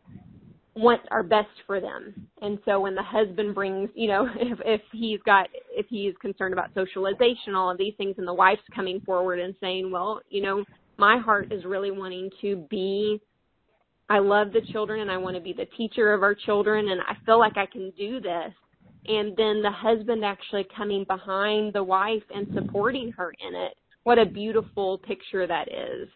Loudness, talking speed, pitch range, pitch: -25 LUFS, 195 wpm, 195-215 Hz, 205 Hz